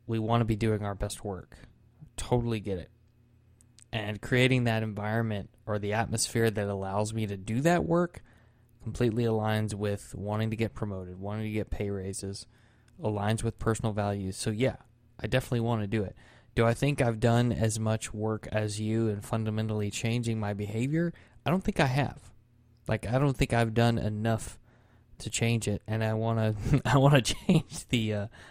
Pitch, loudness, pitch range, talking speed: 110 Hz, -30 LUFS, 105-120 Hz, 185 wpm